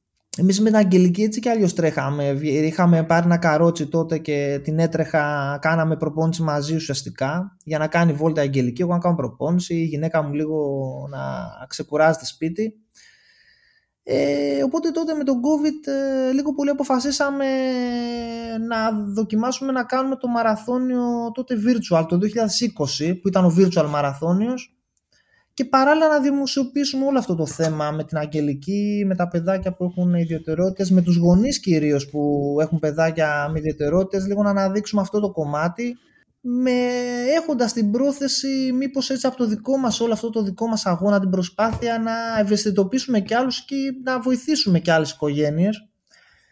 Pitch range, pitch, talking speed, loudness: 160-250 Hz, 200 Hz, 155 wpm, -21 LUFS